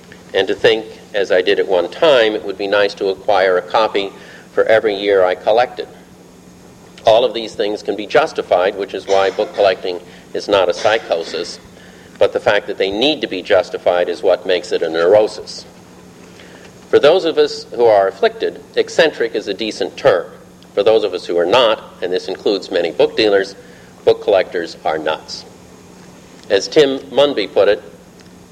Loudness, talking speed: -15 LUFS, 185 wpm